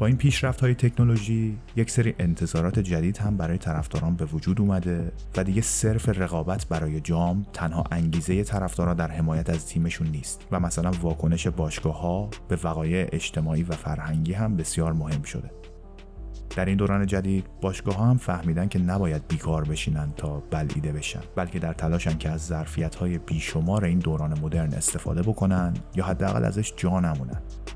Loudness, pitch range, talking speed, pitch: -26 LUFS, 80-95 Hz, 165 wpm, 85 Hz